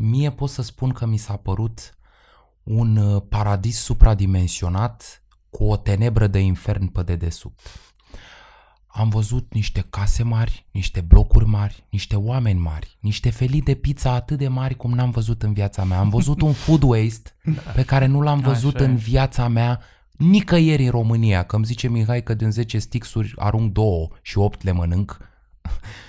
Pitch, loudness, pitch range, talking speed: 110 Hz, -20 LUFS, 100-125 Hz, 165 wpm